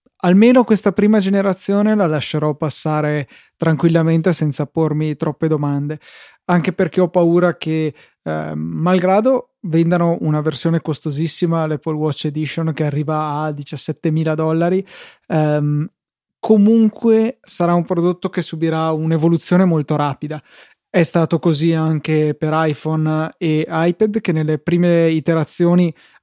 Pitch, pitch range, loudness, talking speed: 165 Hz, 155-180 Hz, -17 LUFS, 120 wpm